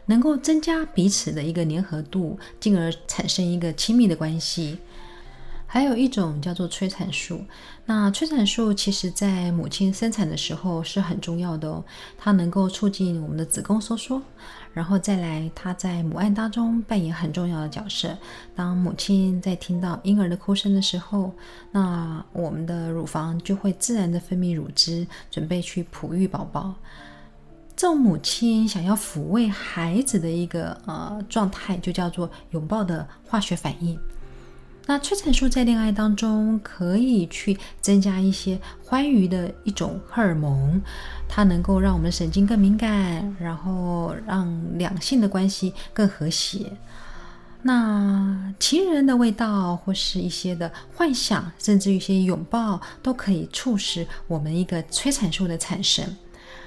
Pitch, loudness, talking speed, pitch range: 190 Hz, -23 LUFS, 235 characters per minute, 175-210 Hz